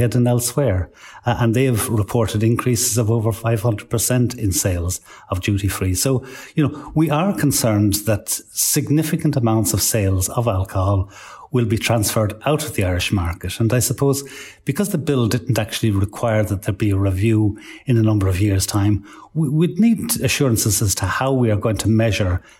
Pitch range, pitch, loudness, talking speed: 105-130 Hz, 115 Hz, -19 LUFS, 180 wpm